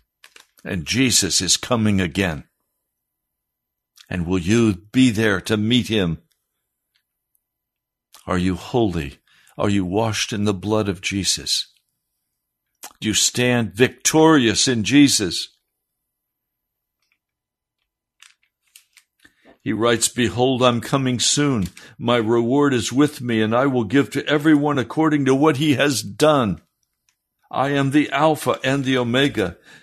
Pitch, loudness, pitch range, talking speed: 120 Hz, -19 LUFS, 105-140 Hz, 120 wpm